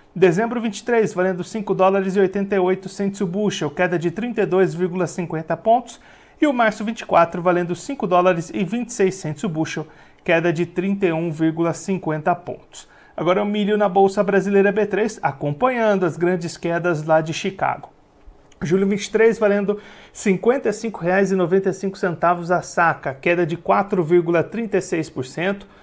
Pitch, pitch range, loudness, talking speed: 190 Hz, 170-205 Hz, -20 LUFS, 110 wpm